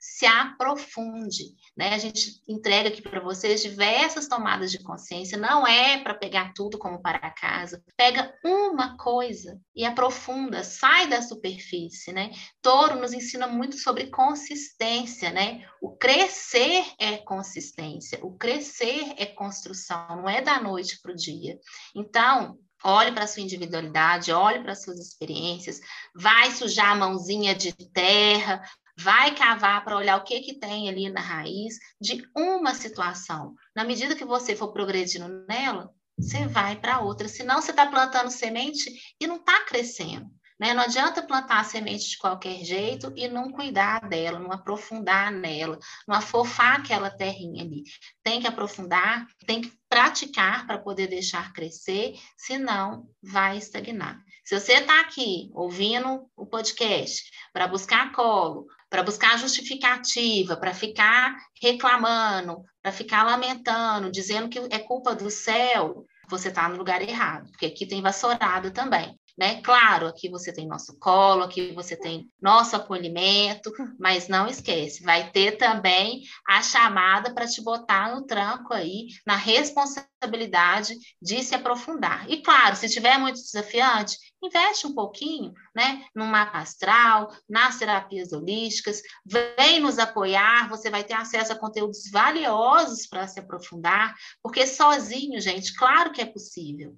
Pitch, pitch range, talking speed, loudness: 215 Hz, 190-245 Hz, 150 wpm, -23 LUFS